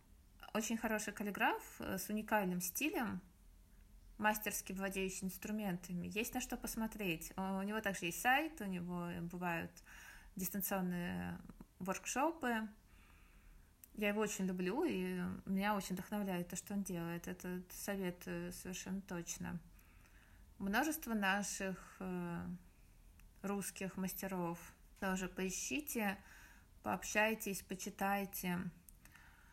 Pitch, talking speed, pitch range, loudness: 190 Hz, 95 wpm, 180-210 Hz, -41 LUFS